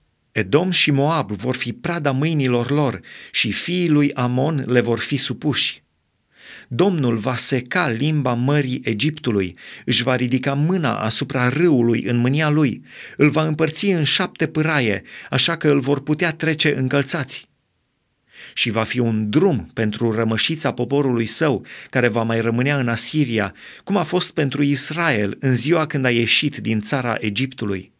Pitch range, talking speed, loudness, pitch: 120-150 Hz, 155 wpm, -19 LUFS, 135 Hz